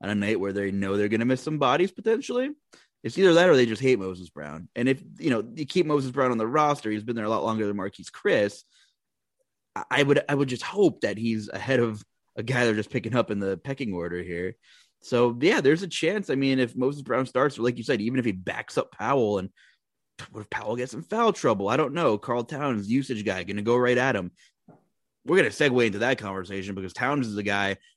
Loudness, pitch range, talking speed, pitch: -25 LUFS, 100-145 Hz, 245 wpm, 120 Hz